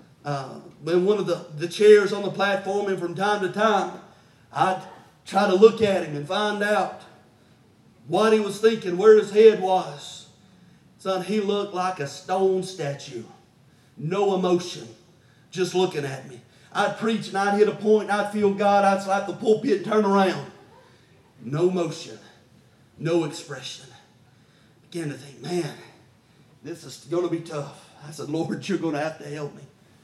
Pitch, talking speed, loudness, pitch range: 180 Hz, 175 wpm, -23 LUFS, 150-200 Hz